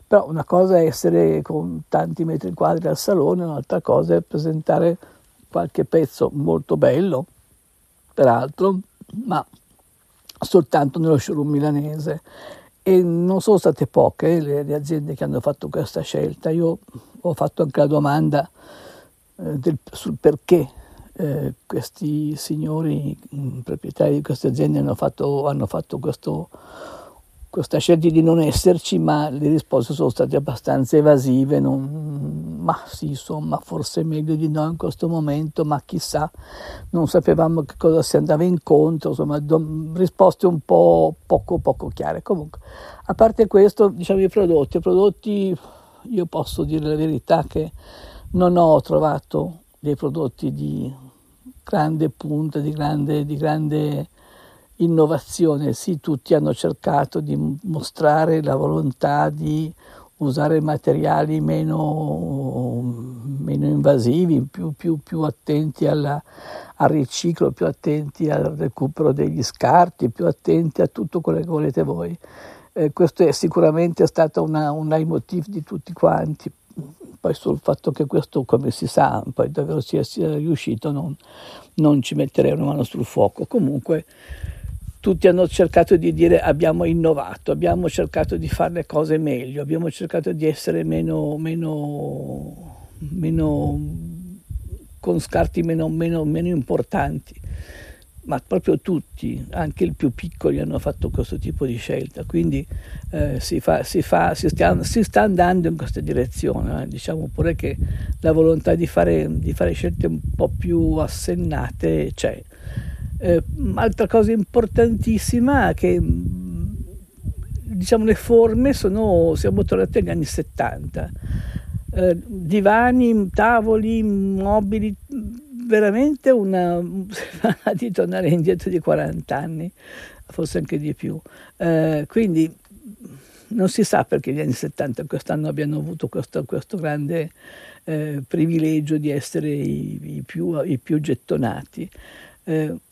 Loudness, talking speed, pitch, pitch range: -20 LUFS, 135 wpm, 155 Hz, 145-180 Hz